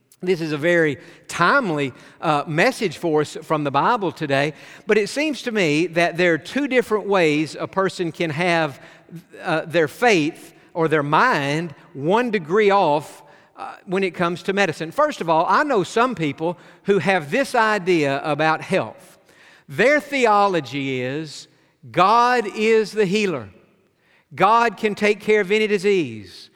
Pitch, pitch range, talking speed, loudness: 175 Hz, 155-210 Hz, 160 wpm, -20 LUFS